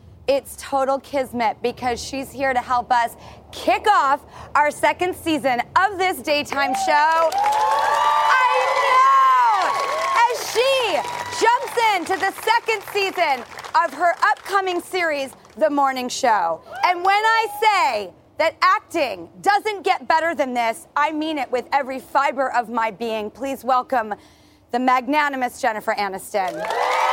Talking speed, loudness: 135 wpm, -20 LUFS